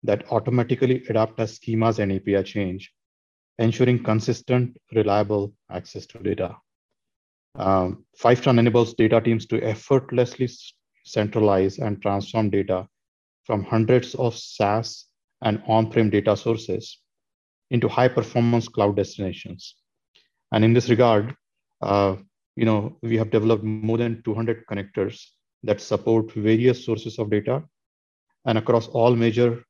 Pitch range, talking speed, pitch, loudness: 105-120 Hz, 125 wpm, 110 Hz, -22 LUFS